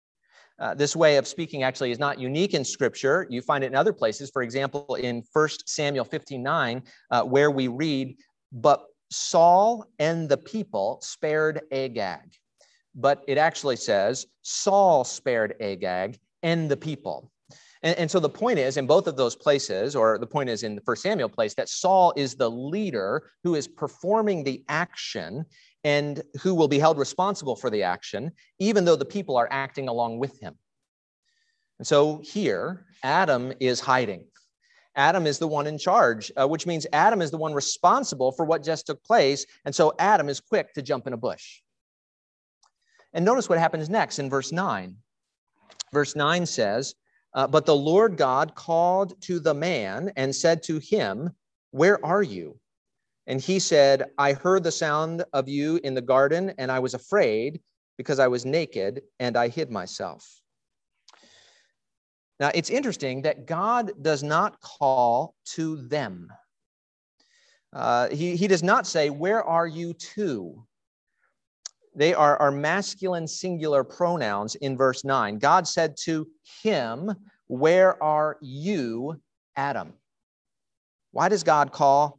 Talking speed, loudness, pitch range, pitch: 160 wpm, -24 LUFS, 135-175 Hz, 150 Hz